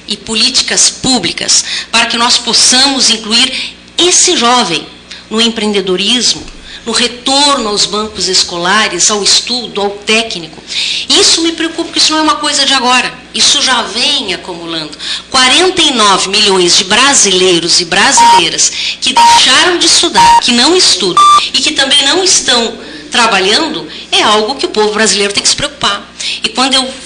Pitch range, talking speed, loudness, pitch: 210-300 Hz, 150 wpm, -7 LUFS, 245 Hz